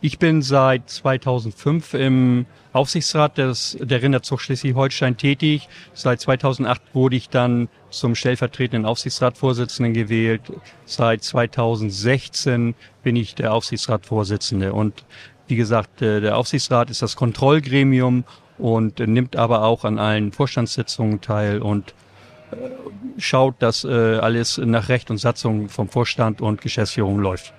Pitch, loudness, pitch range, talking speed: 125 Hz, -20 LUFS, 110-135 Hz, 120 wpm